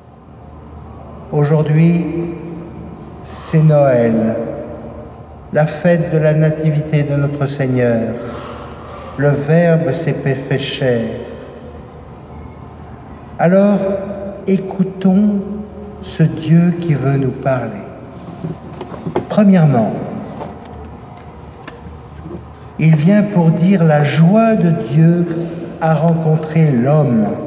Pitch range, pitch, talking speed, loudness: 140-170 Hz, 155 Hz, 80 wpm, -14 LUFS